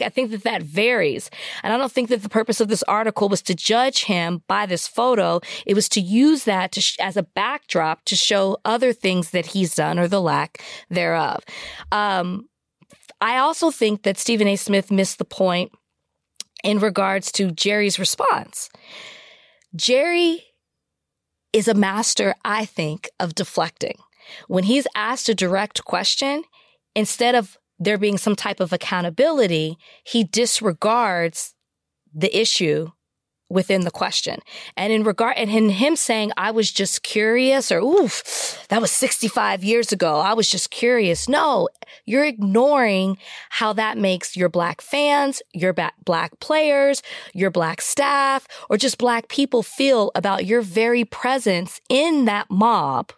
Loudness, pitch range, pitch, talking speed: -20 LUFS, 190-245 Hz, 215 Hz, 155 wpm